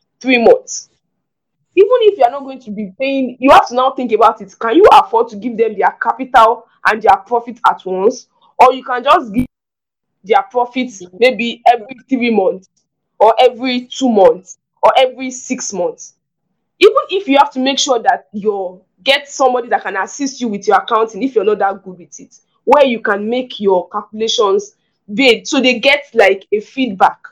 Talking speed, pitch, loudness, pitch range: 195 wpm, 250 Hz, -13 LUFS, 215-275 Hz